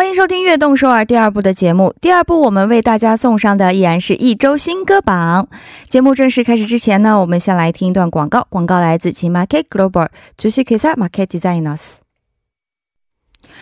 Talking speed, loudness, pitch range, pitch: 400 characters per minute, -12 LUFS, 185-265 Hz, 215 Hz